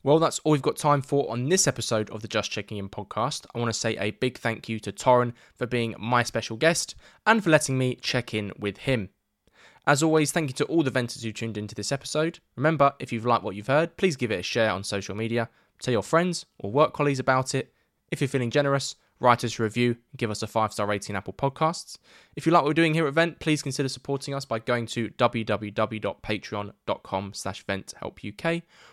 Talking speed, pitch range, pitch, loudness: 225 wpm, 110-145 Hz, 125 Hz, -26 LUFS